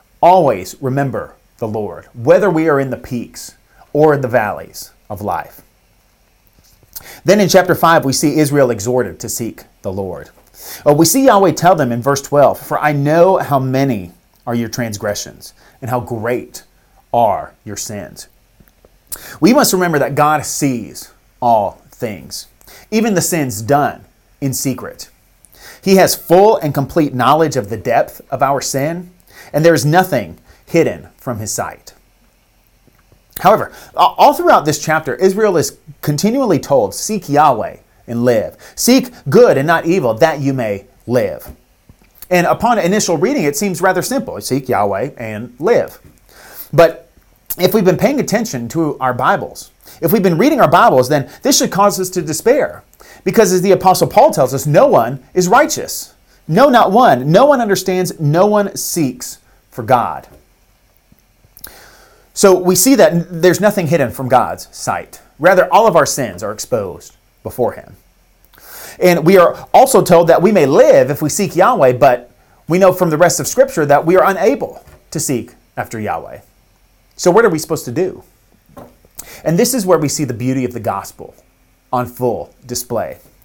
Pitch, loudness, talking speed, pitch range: 155 Hz, -13 LUFS, 165 wpm, 130-185 Hz